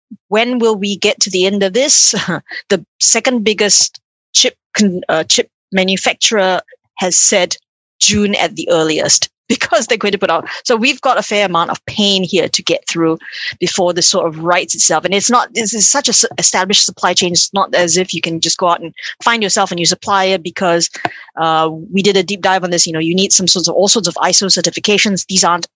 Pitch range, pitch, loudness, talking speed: 175-210 Hz, 190 Hz, -12 LUFS, 220 wpm